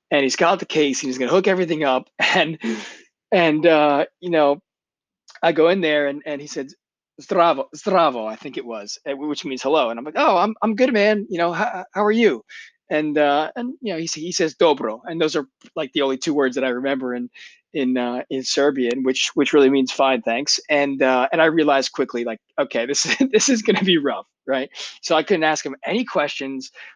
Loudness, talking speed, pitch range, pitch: -20 LUFS, 230 wpm, 135-175 Hz, 150 Hz